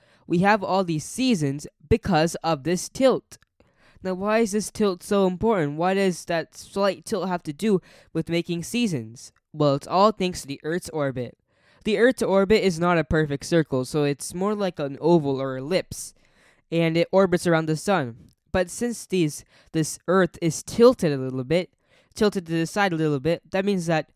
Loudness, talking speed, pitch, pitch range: -24 LUFS, 190 wpm, 170 Hz, 155-195 Hz